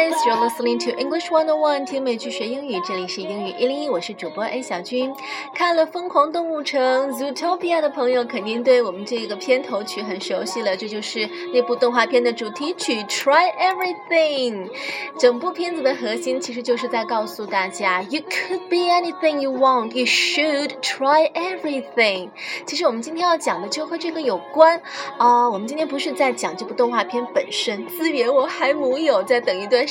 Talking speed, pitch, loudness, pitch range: 435 characters per minute, 270 Hz, -21 LUFS, 240-320 Hz